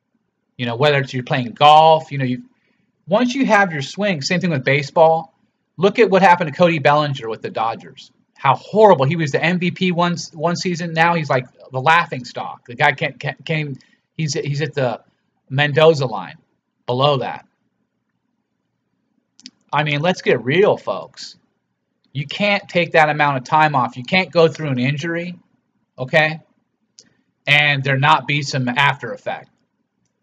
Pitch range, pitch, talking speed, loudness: 140-175 Hz, 155 Hz, 170 wpm, -17 LUFS